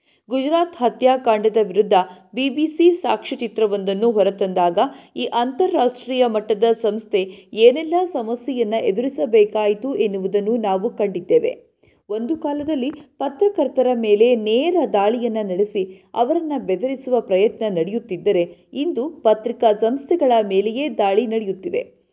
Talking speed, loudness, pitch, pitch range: 90 wpm, -19 LUFS, 235 Hz, 210-275 Hz